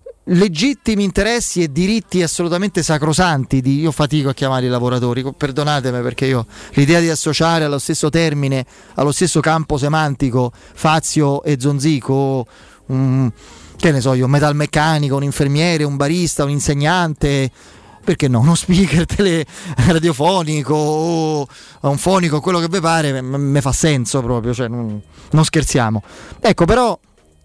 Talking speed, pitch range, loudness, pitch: 140 wpm, 135-165 Hz, -16 LUFS, 150 Hz